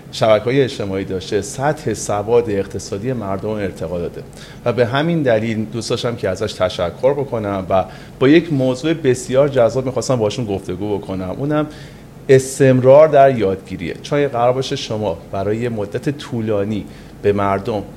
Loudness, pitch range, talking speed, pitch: -17 LUFS, 100-135 Hz, 140 wpm, 115 Hz